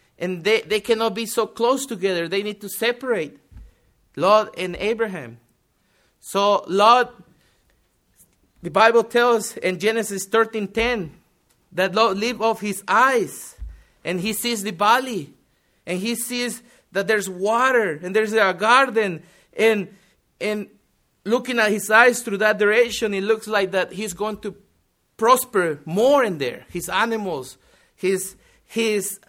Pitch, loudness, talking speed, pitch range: 215 Hz, -20 LUFS, 140 wpm, 190-225 Hz